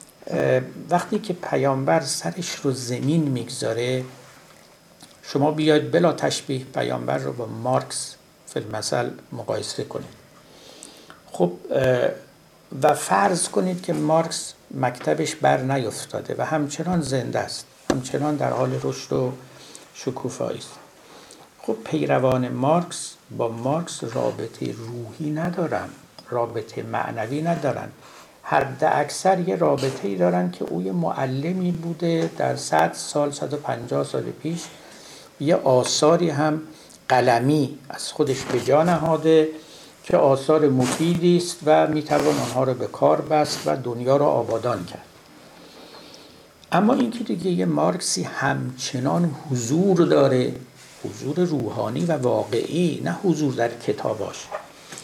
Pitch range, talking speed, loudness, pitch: 130-165 Hz, 120 wpm, -23 LUFS, 150 Hz